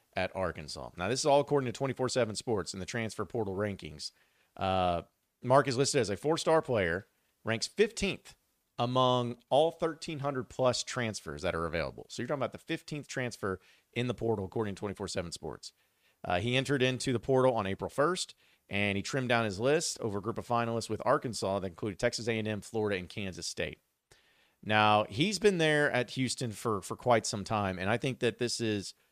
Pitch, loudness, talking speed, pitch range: 115 Hz, -32 LUFS, 205 wpm, 100-130 Hz